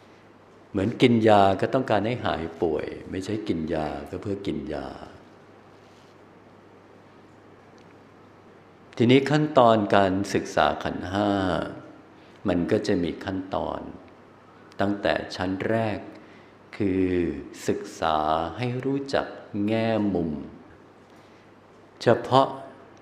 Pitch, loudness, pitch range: 100 Hz, -25 LUFS, 90-115 Hz